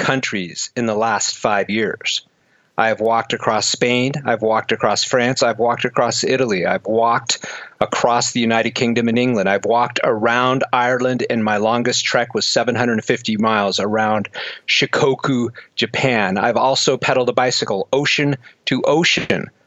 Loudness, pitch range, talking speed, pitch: -17 LUFS, 110-125 Hz, 150 wpm, 120 Hz